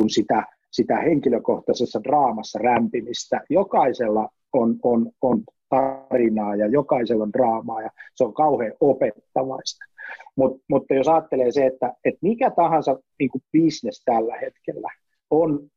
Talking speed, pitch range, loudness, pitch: 125 wpm, 125-155 Hz, -22 LUFS, 135 Hz